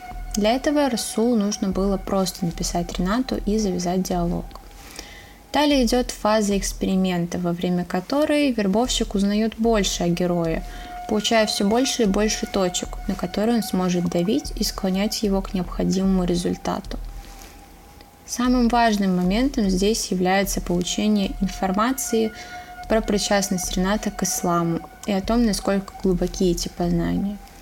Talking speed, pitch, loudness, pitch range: 130 wpm, 205 Hz, -22 LUFS, 185-230 Hz